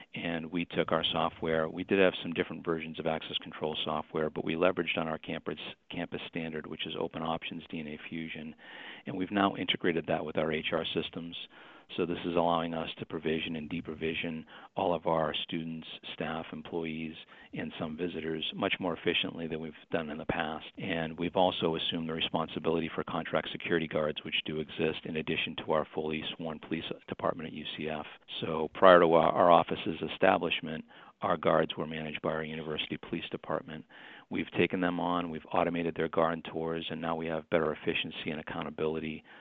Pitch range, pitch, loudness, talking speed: 80-85 Hz, 80 Hz, -32 LUFS, 185 wpm